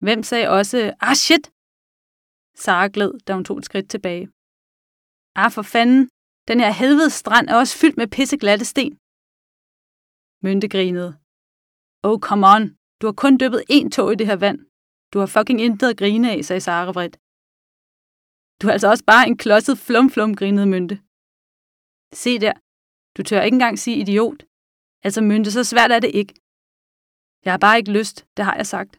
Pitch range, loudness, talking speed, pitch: 200-245 Hz, -17 LUFS, 180 wpm, 215 Hz